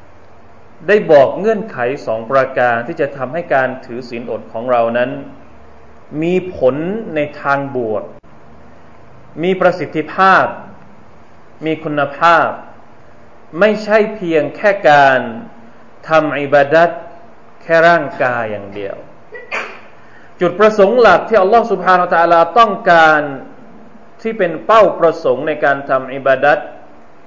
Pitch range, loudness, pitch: 125-185 Hz, -13 LUFS, 155 Hz